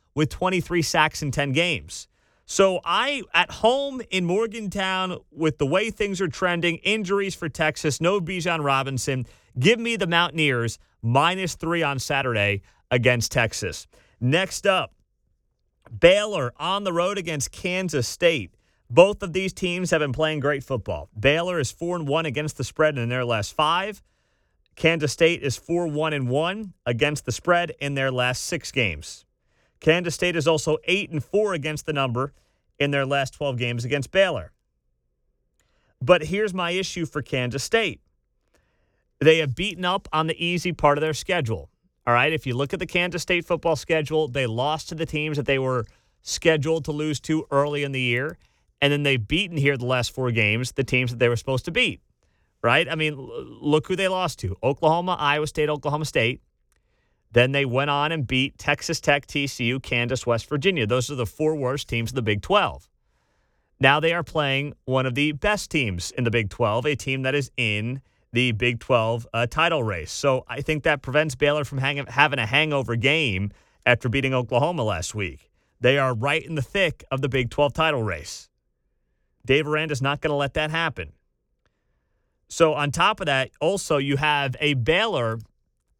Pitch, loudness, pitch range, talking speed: 145 Hz, -23 LUFS, 125-165 Hz, 185 wpm